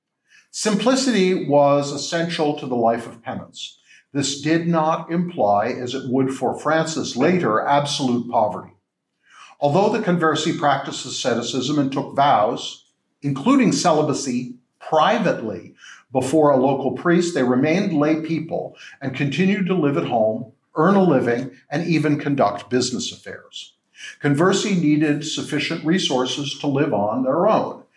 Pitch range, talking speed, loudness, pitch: 130-165 Hz, 135 wpm, -20 LUFS, 145 Hz